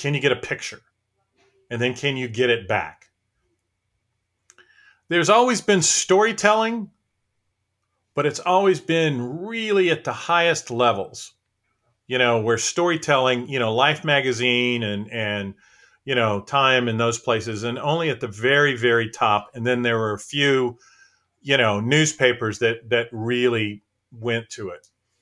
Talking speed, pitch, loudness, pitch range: 150 wpm, 120 Hz, -21 LUFS, 110-145 Hz